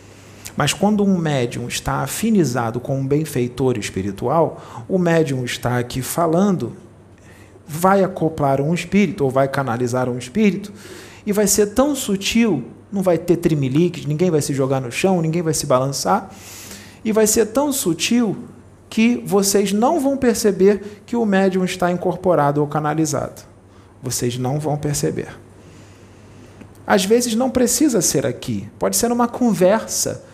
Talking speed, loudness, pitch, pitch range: 145 wpm, -18 LUFS, 160 Hz, 125-200 Hz